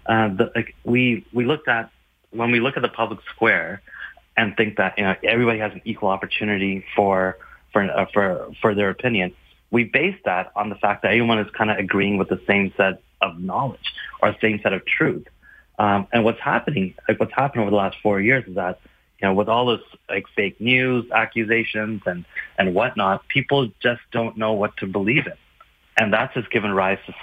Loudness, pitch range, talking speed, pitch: -21 LUFS, 100-115 Hz, 205 wpm, 110 Hz